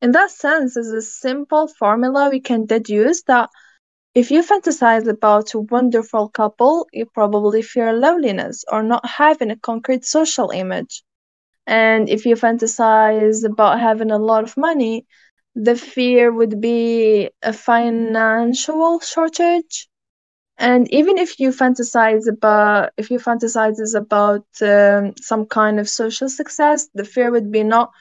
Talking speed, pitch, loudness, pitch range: 145 wpm, 230 Hz, -16 LUFS, 220-260 Hz